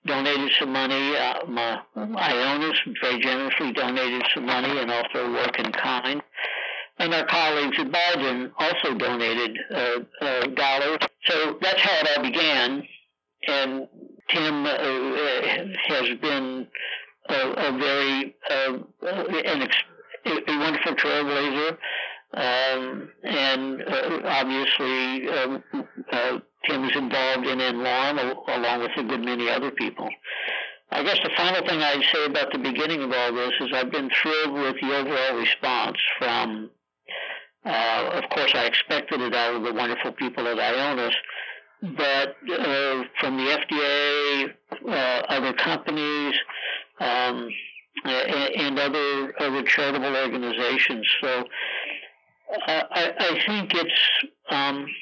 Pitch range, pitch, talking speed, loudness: 125-145 Hz, 135 Hz, 130 wpm, -24 LUFS